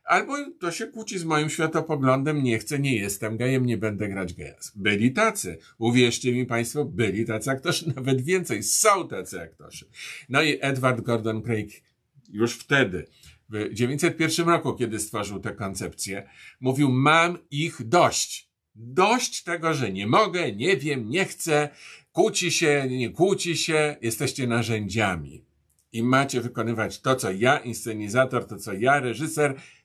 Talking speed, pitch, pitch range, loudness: 150 wpm, 130 Hz, 115-155 Hz, -24 LUFS